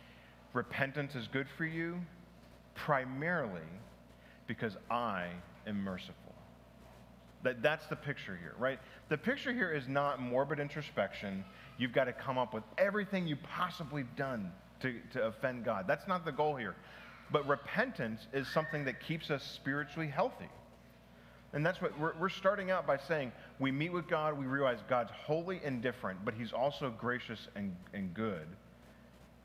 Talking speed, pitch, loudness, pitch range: 155 wpm, 135 Hz, -37 LUFS, 110-160 Hz